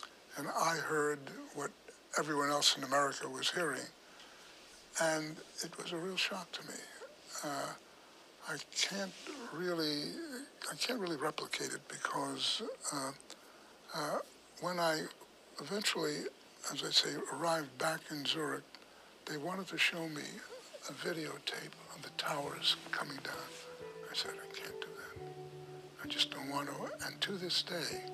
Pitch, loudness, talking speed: 165 Hz, -37 LUFS, 145 wpm